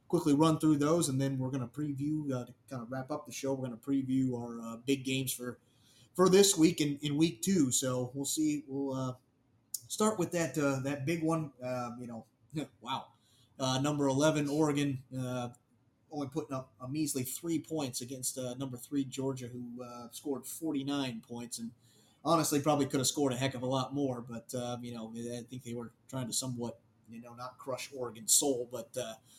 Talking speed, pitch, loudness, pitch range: 215 wpm, 130 Hz, -33 LUFS, 120-145 Hz